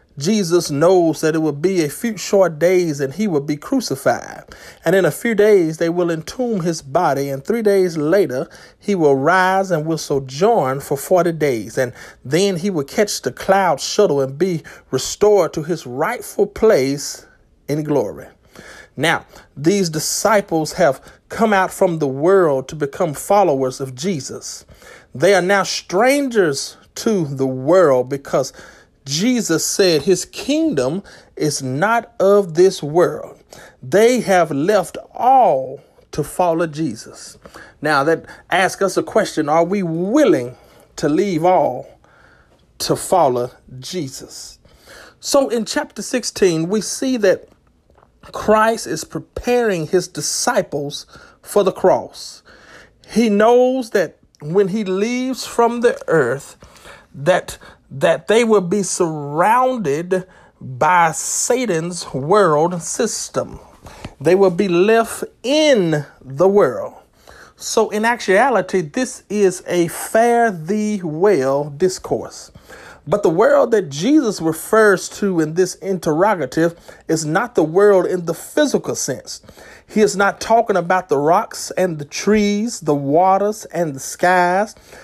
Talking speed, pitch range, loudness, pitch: 135 wpm, 155-210 Hz, -17 LUFS, 185 Hz